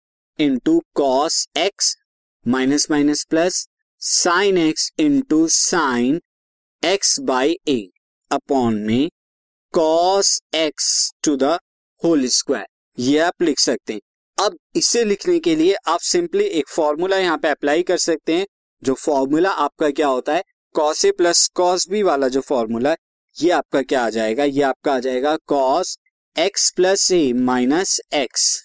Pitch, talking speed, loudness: 180 Hz, 140 wpm, -18 LUFS